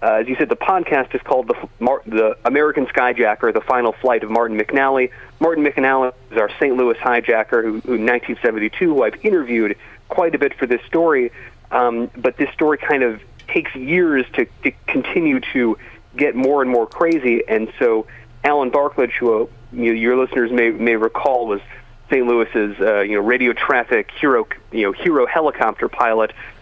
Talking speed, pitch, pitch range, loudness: 185 wpm, 120 Hz, 115-135 Hz, -18 LUFS